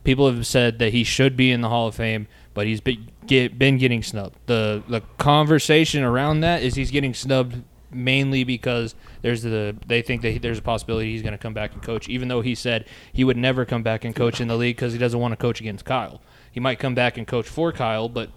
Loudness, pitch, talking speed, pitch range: -22 LUFS, 120 Hz, 250 wpm, 115-130 Hz